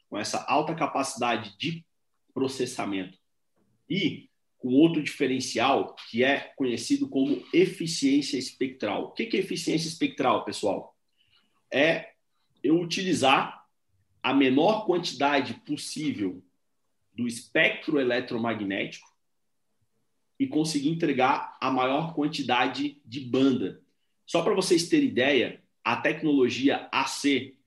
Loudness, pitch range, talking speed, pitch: -26 LUFS, 120-165 Hz, 105 wpm, 140 Hz